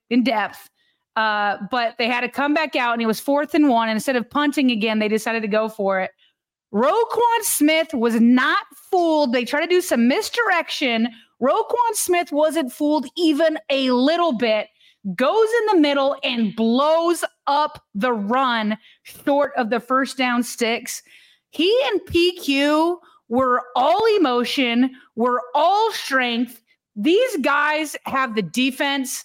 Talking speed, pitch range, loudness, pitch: 155 wpm, 240-320 Hz, -20 LUFS, 275 Hz